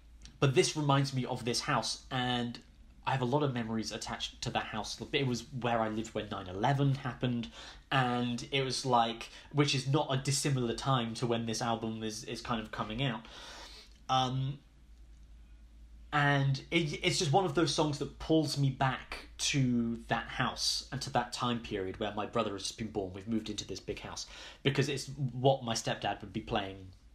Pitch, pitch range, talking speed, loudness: 120 Hz, 110-135 Hz, 195 wpm, -33 LUFS